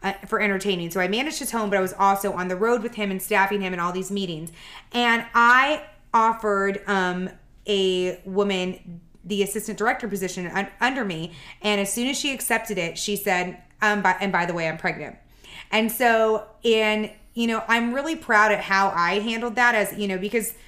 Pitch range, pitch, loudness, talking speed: 185-230 Hz, 205 Hz, -23 LUFS, 205 wpm